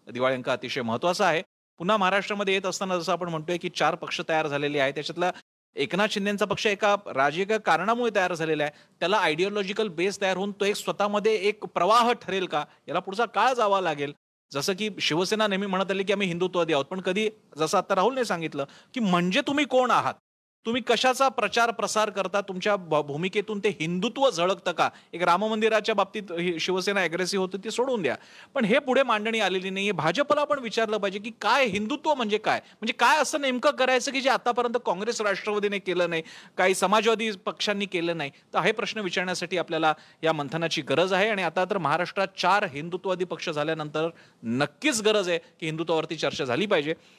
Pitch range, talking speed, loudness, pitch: 170-215 Hz, 185 wpm, -26 LUFS, 195 Hz